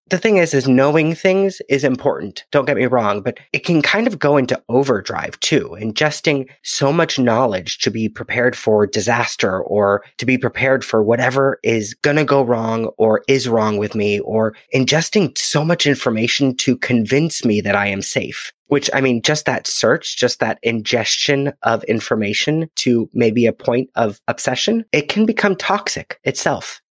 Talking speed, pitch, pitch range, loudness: 180 wpm, 130 Hz, 115-150 Hz, -17 LUFS